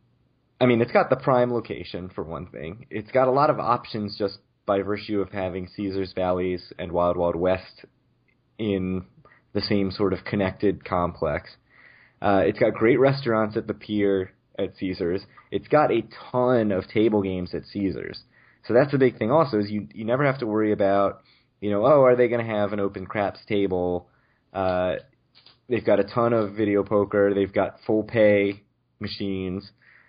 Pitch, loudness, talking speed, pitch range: 100 Hz, -24 LUFS, 185 wpm, 95-115 Hz